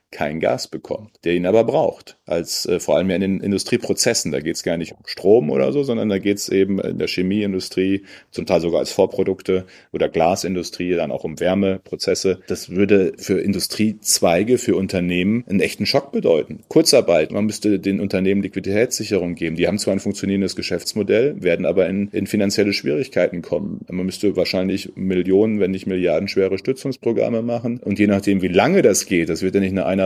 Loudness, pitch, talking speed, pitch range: -19 LUFS, 95 Hz, 190 wpm, 95-100 Hz